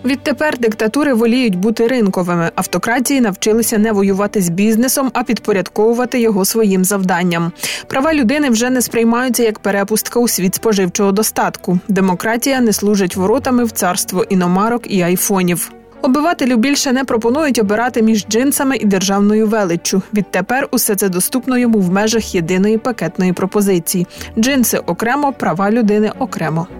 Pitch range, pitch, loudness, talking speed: 195-245 Hz, 220 Hz, -14 LUFS, 135 wpm